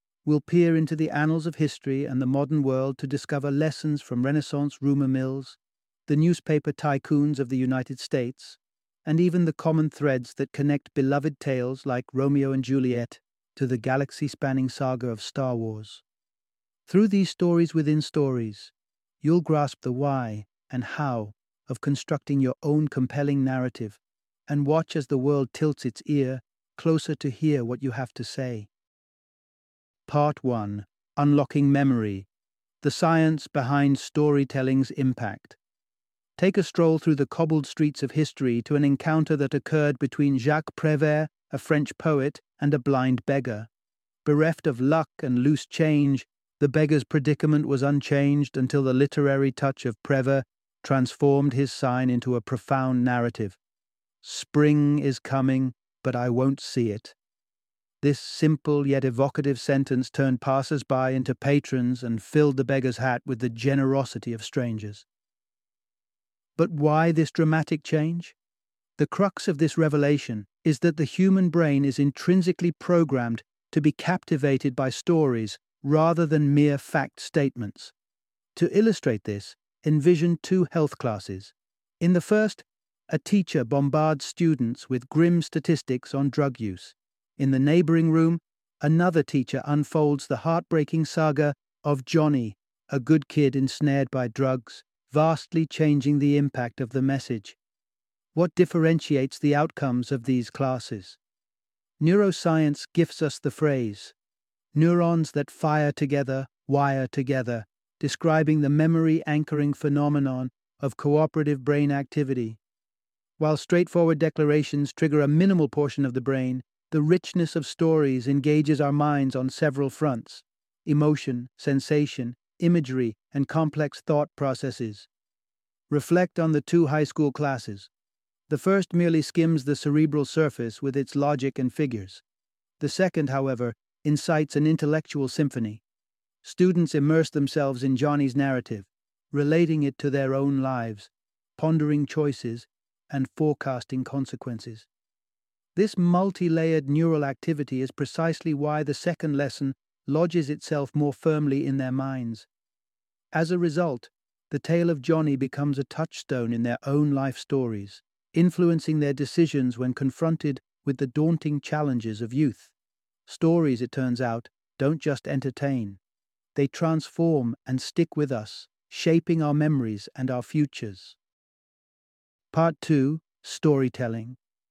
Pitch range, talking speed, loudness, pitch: 130-155 Hz, 135 wpm, -25 LUFS, 145 Hz